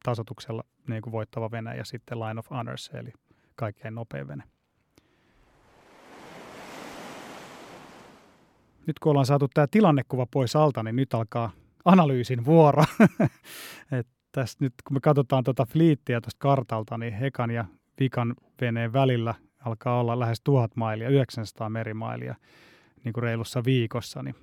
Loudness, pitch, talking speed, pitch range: -26 LUFS, 120 Hz, 135 wpm, 115-140 Hz